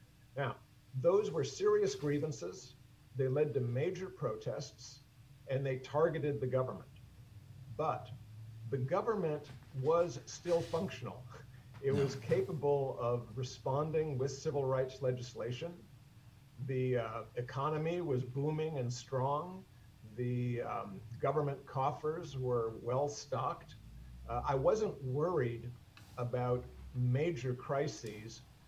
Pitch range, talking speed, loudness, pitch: 120-145 Hz, 105 wpm, -37 LUFS, 130 Hz